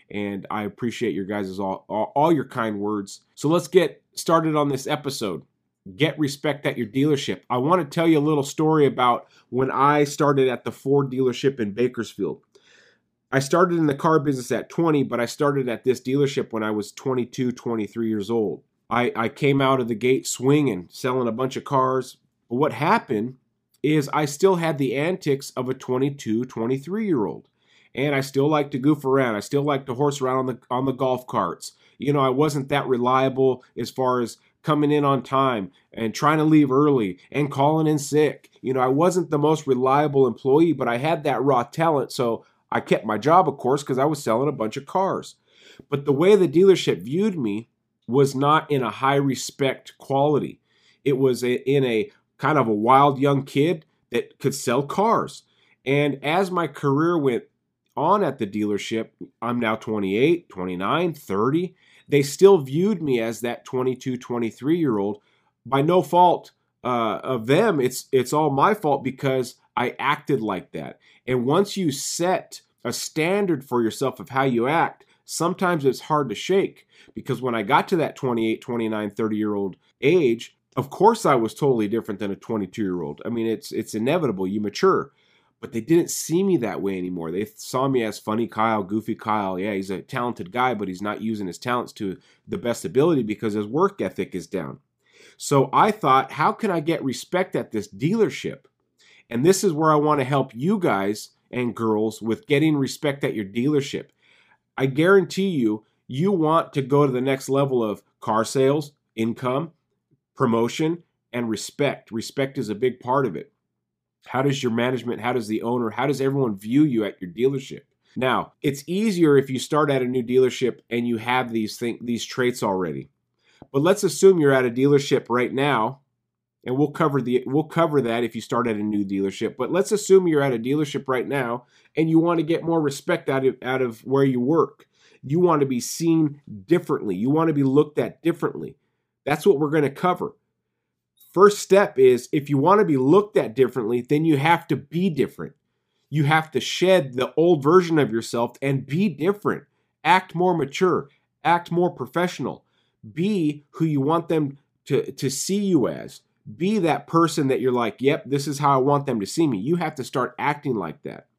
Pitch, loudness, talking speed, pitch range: 135 Hz, -22 LUFS, 195 wpm, 120-155 Hz